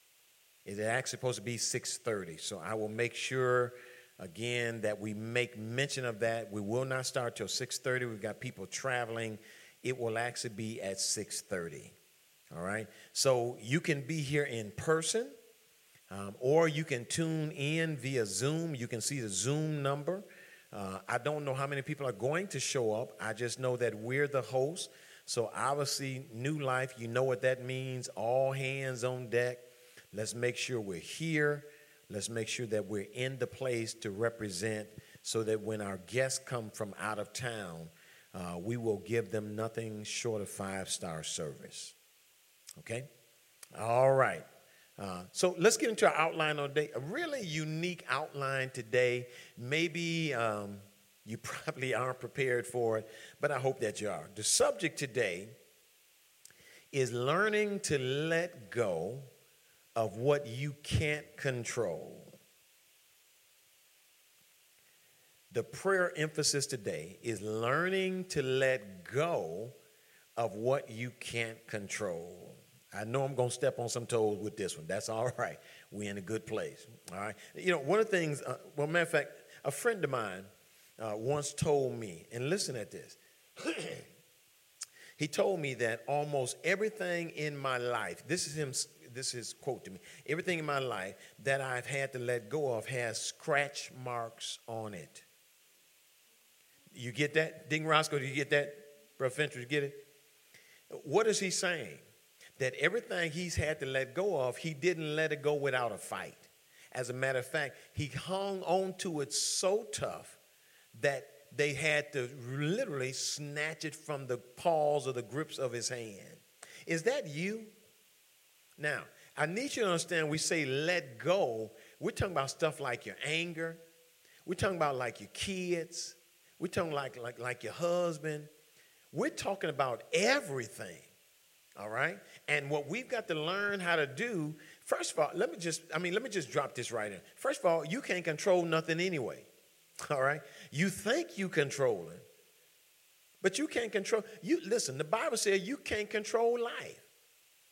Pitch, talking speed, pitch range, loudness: 135 Hz, 165 wpm, 120-160 Hz, -35 LUFS